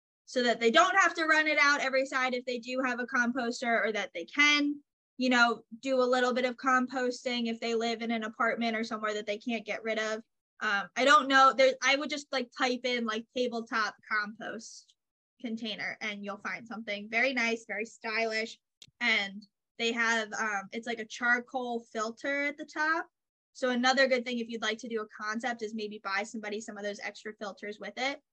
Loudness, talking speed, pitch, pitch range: -29 LUFS, 210 wpm, 235 Hz, 220-255 Hz